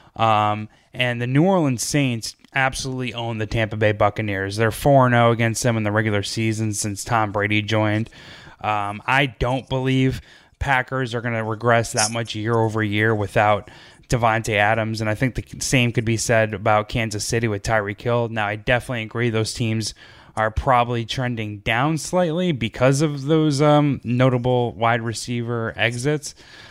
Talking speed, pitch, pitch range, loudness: 165 wpm, 115 Hz, 110-125 Hz, -21 LUFS